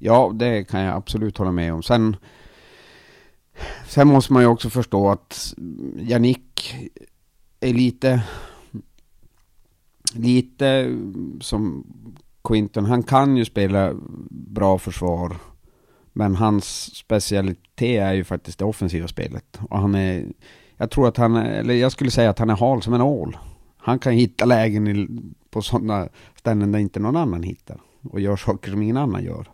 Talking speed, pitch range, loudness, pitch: 155 wpm, 100-120 Hz, -20 LUFS, 110 Hz